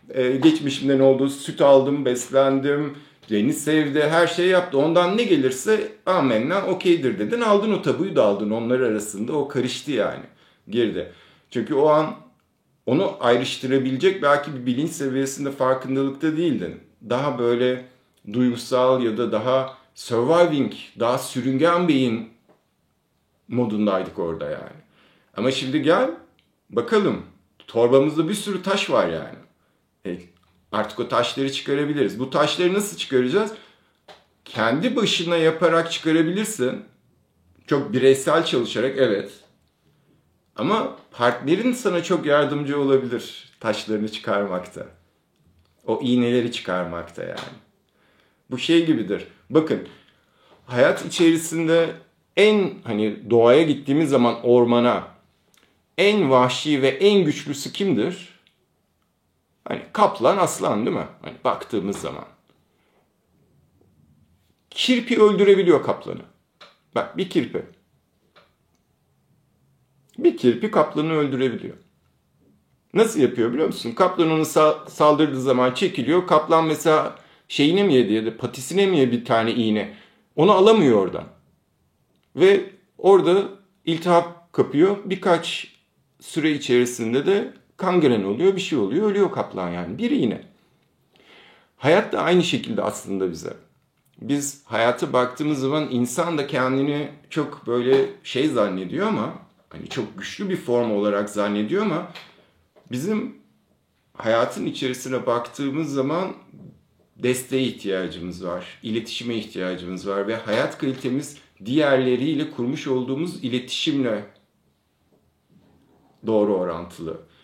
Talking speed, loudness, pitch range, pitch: 110 wpm, -21 LUFS, 120-165 Hz, 135 Hz